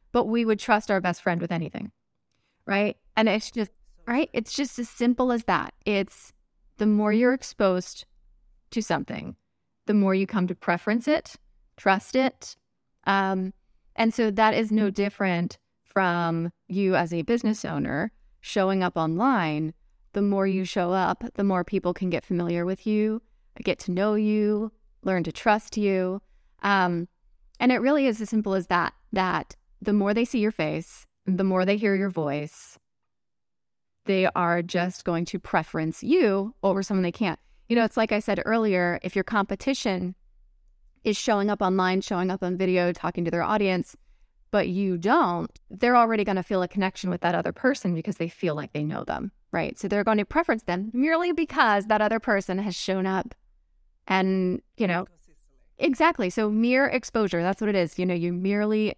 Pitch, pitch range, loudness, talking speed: 195 Hz, 180-220 Hz, -25 LUFS, 180 wpm